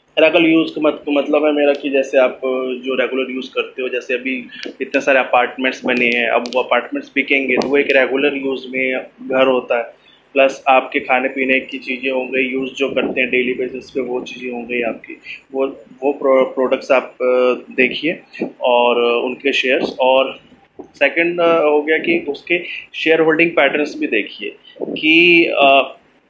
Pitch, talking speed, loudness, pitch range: 135 Hz, 170 wpm, -16 LUFS, 130-150 Hz